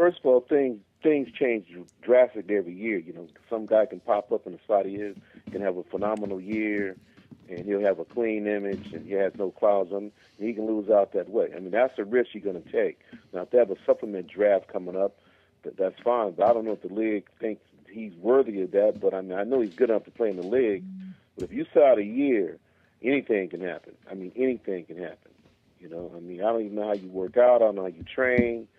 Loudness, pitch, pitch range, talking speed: -26 LUFS, 110 Hz, 100-130 Hz, 255 wpm